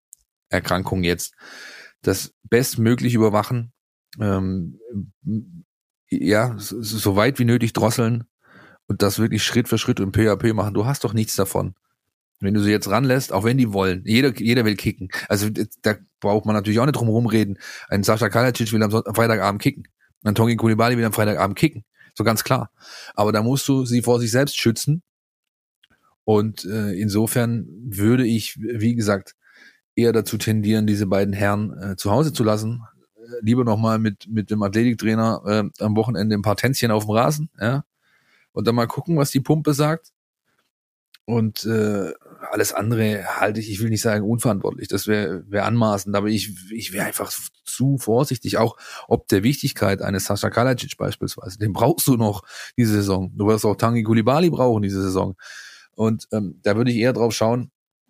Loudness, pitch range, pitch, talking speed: -21 LUFS, 105-120 Hz, 110 Hz, 175 wpm